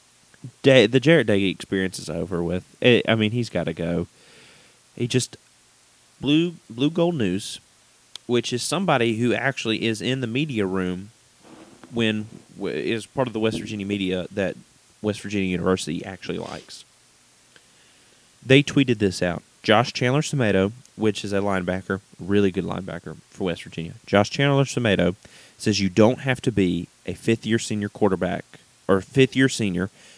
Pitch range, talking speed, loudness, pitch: 95-125 Hz, 165 wpm, -23 LUFS, 110 Hz